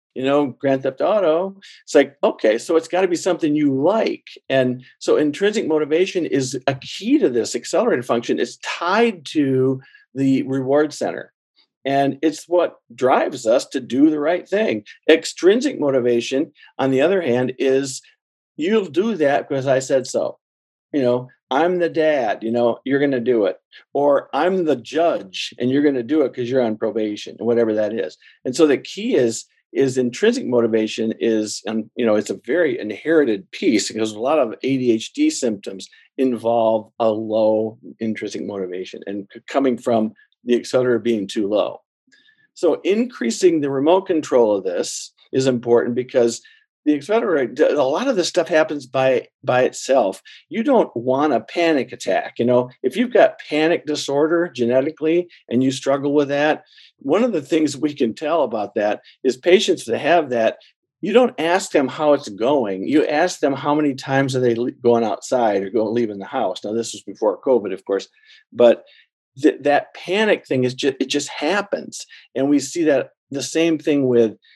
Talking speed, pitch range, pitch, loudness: 180 wpm, 120-170 Hz, 140 Hz, -19 LUFS